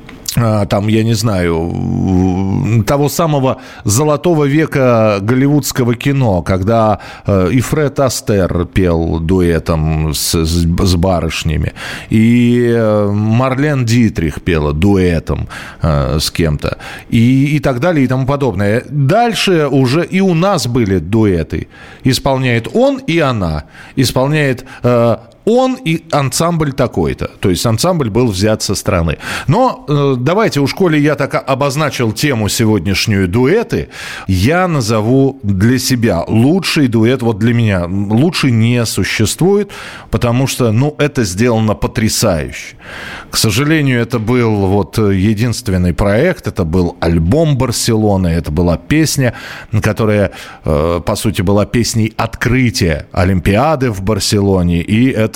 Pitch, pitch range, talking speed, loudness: 115 Hz, 95-135 Hz, 120 wpm, -13 LUFS